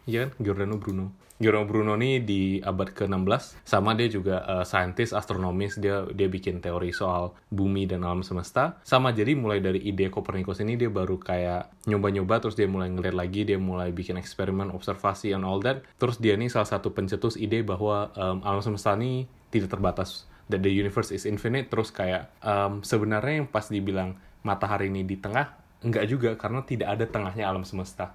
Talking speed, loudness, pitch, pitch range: 185 wpm, -28 LUFS, 100 Hz, 95-110 Hz